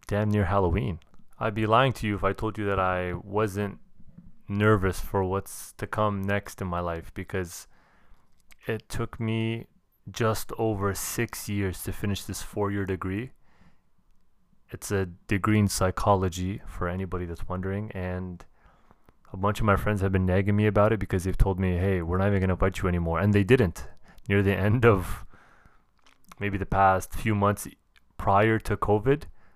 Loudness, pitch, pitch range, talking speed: -27 LUFS, 100 Hz, 95-105 Hz, 175 wpm